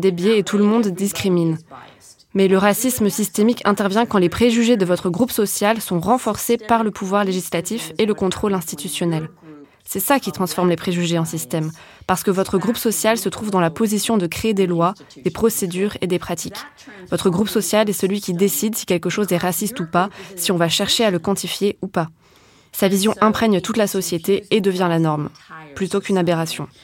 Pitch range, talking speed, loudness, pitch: 180-215 Hz, 205 wpm, -19 LUFS, 195 Hz